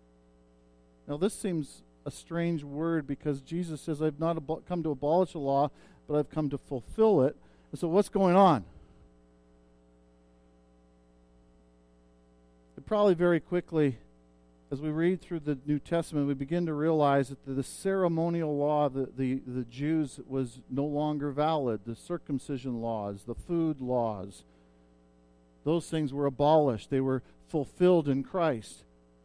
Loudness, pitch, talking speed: -30 LUFS, 140 Hz, 145 wpm